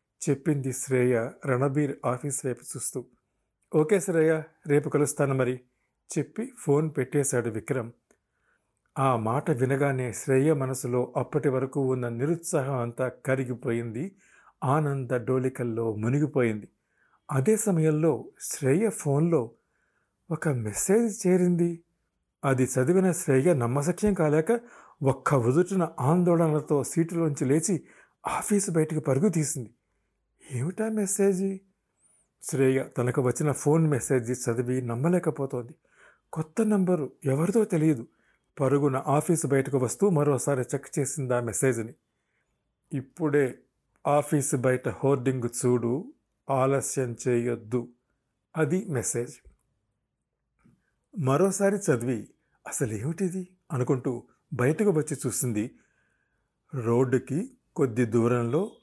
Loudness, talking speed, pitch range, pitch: -27 LUFS, 95 wpm, 125-165 Hz, 140 Hz